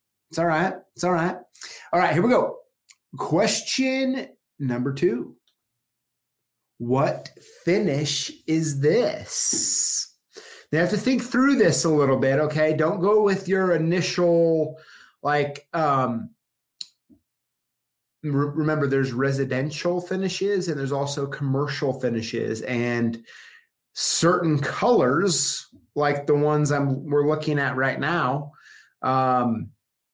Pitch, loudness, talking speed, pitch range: 145 Hz, -23 LUFS, 115 wpm, 130-170 Hz